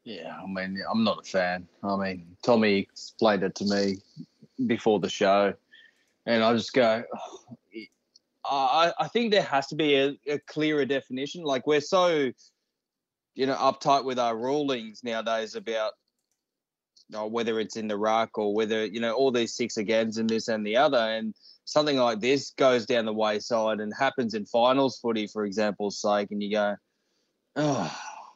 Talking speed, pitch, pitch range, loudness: 180 wpm, 115 Hz, 105-135 Hz, -26 LUFS